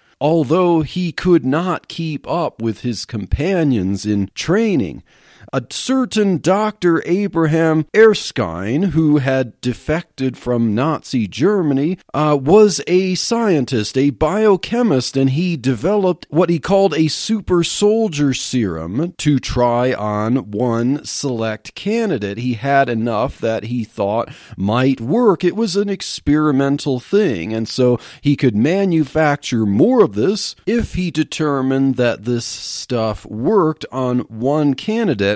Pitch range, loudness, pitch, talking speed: 125-180 Hz, -17 LUFS, 145 Hz, 125 wpm